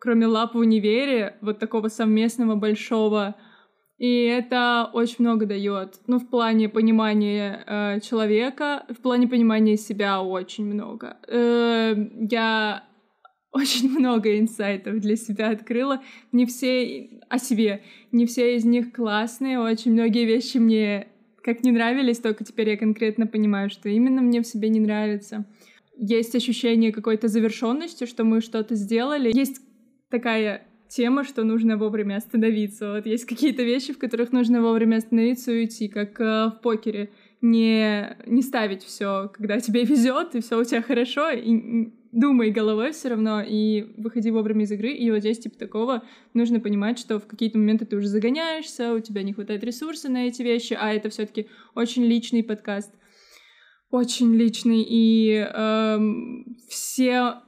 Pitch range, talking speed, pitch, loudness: 215-240 Hz, 155 wpm, 225 Hz, -23 LUFS